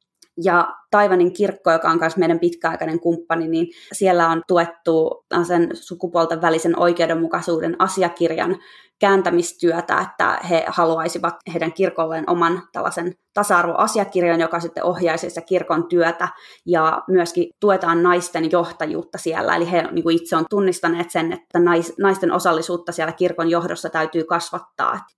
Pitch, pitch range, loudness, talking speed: 170 Hz, 165-180 Hz, -19 LUFS, 130 wpm